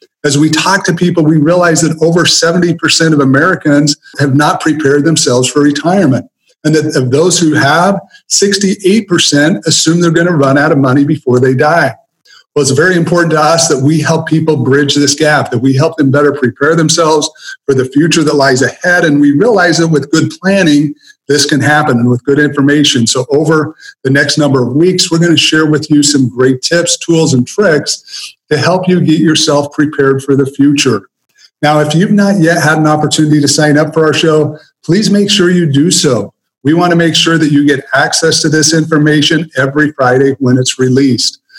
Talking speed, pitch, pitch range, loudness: 205 wpm, 155 Hz, 145-170 Hz, -9 LUFS